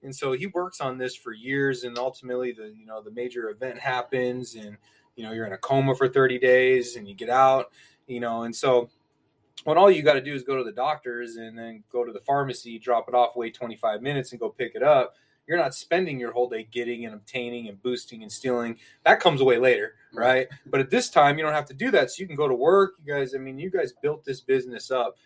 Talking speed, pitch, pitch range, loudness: 255 wpm, 125 Hz, 120-135 Hz, -24 LUFS